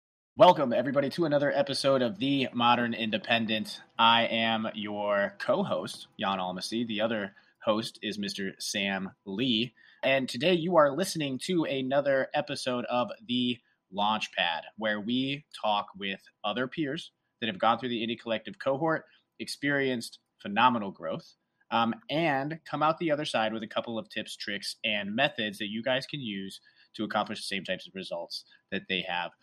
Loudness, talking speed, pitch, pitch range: -29 LUFS, 165 wpm, 120 Hz, 110-140 Hz